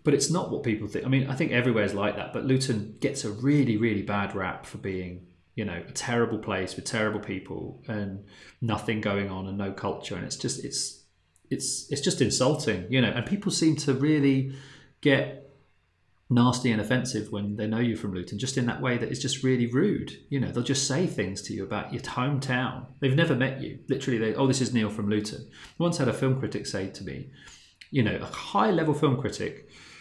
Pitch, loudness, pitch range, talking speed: 120 Hz, -27 LUFS, 105-135 Hz, 225 wpm